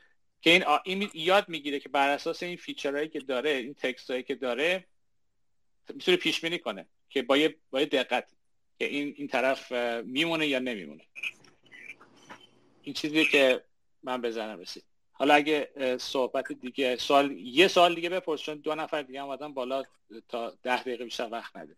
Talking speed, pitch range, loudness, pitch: 155 wpm, 130-160 Hz, -28 LUFS, 145 Hz